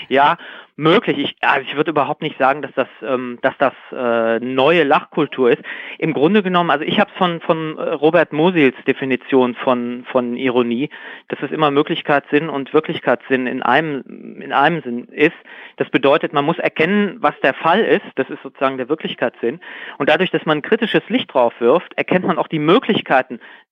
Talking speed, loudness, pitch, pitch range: 180 wpm, -17 LUFS, 145 Hz, 130-165 Hz